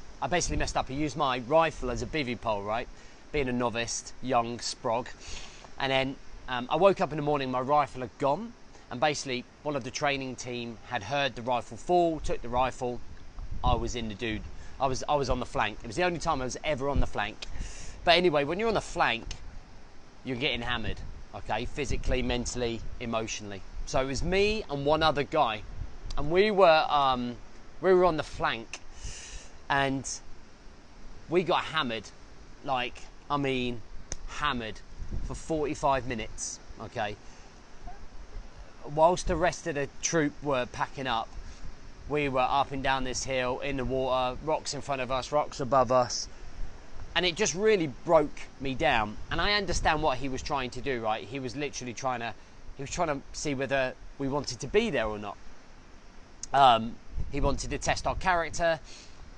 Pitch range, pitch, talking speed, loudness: 110-145 Hz, 130 Hz, 185 wpm, -29 LUFS